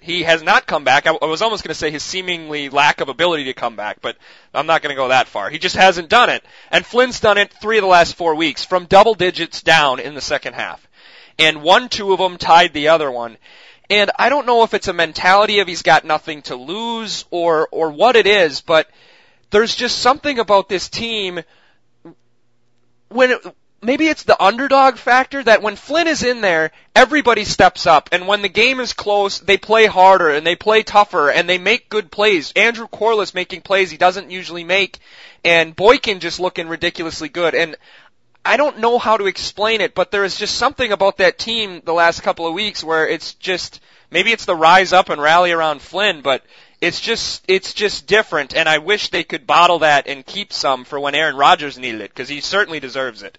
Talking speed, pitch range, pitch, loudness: 215 wpm, 165-220 Hz, 185 Hz, -15 LUFS